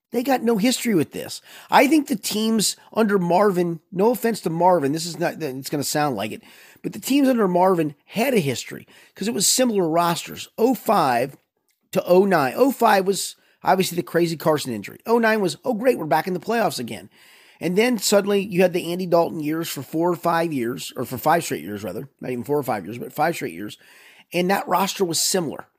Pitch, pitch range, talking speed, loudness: 185 Hz, 165-220 Hz, 215 wpm, -21 LUFS